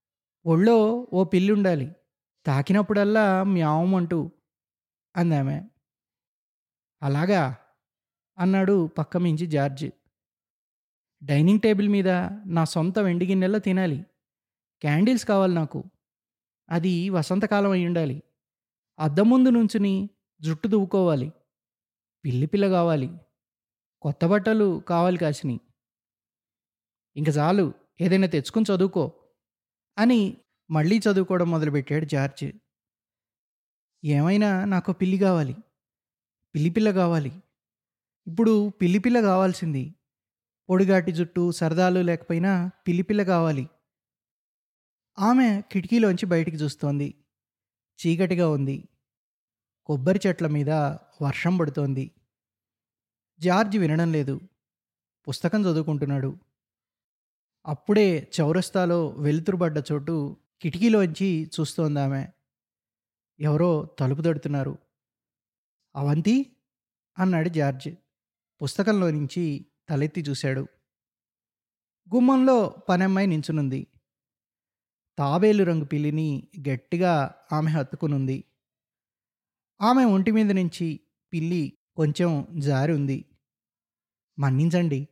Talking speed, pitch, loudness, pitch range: 80 wpm, 165 Hz, -24 LUFS, 145-190 Hz